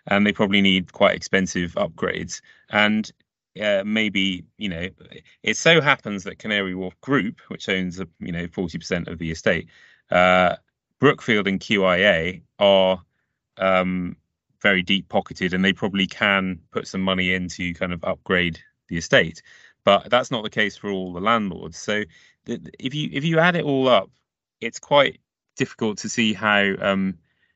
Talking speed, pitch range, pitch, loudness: 170 wpm, 90-105 Hz, 95 Hz, -21 LUFS